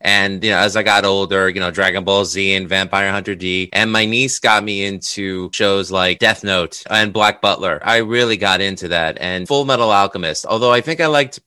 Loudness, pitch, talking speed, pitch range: -15 LUFS, 100 Hz, 225 wpm, 95-110 Hz